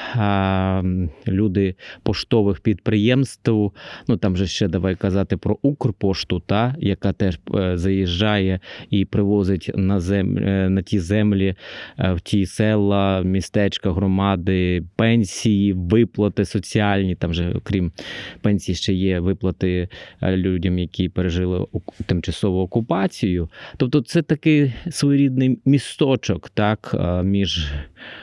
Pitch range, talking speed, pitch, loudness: 95-110 Hz, 105 wpm, 100 Hz, -20 LUFS